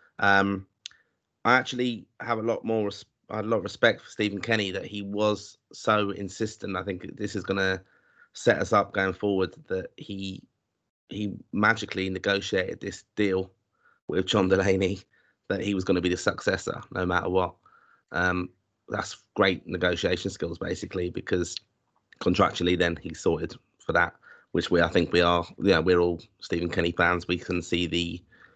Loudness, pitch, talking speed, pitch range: -27 LUFS, 95 Hz, 170 wpm, 90-105 Hz